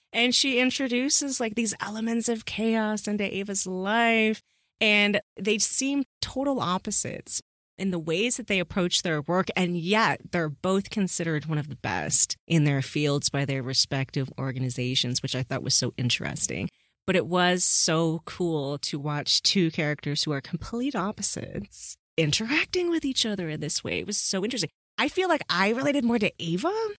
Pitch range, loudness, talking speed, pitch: 150-225 Hz, -25 LUFS, 175 wpm, 185 Hz